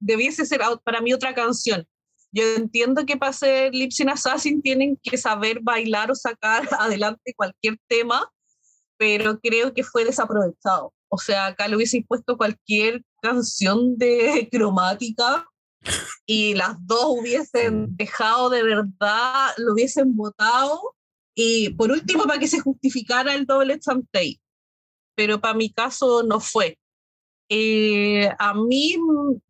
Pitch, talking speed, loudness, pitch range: 235 Hz, 135 wpm, -21 LUFS, 215-265 Hz